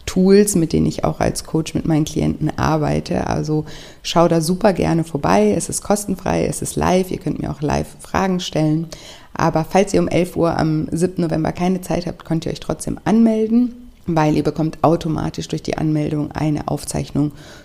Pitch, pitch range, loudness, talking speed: 160 Hz, 155-185 Hz, -19 LUFS, 190 wpm